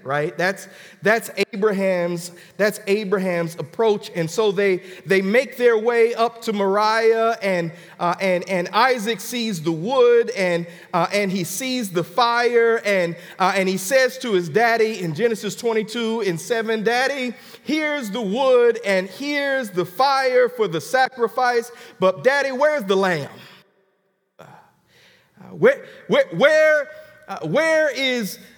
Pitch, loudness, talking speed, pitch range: 220 Hz, -20 LUFS, 145 wpm, 185-250 Hz